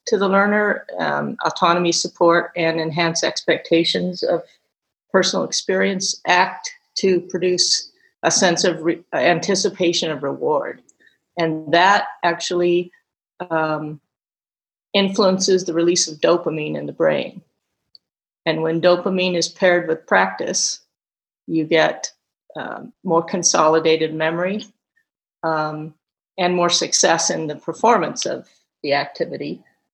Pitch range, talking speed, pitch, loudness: 165-195 Hz, 115 wpm, 175 Hz, -19 LUFS